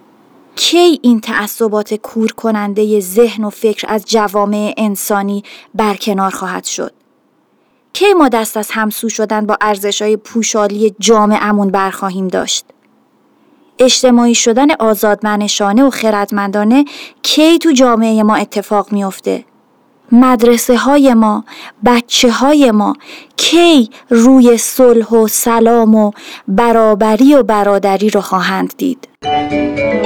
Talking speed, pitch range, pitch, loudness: 115 wpm, 205-245 Hz, 220 Hz, -11 LUFS